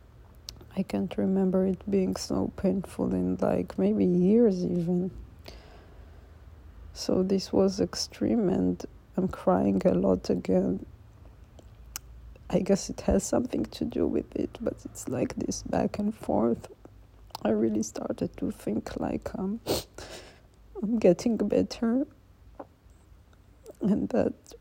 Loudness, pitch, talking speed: -28 LUFS, 115 Hz, 120 wpm